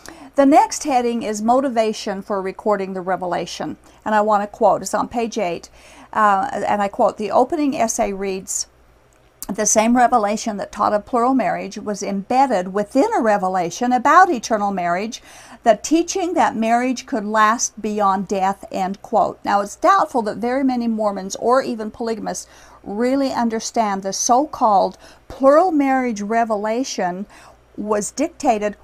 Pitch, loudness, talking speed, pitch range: 225 Hz, -19 LUFS, 150 wpm, 205-250 Hz